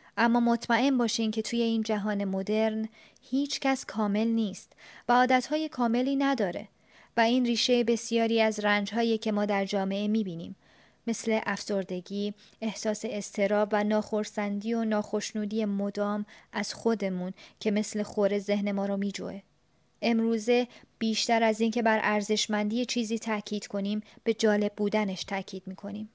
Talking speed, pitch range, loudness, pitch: 135 wpm, 205-230 Hz, -28 LUFS, 215 Hz